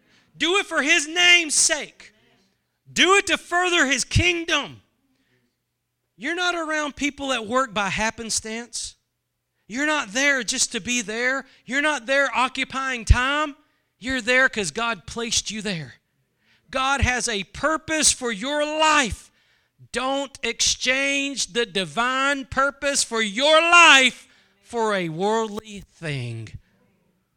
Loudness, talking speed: -20 LUFS, 125 wpm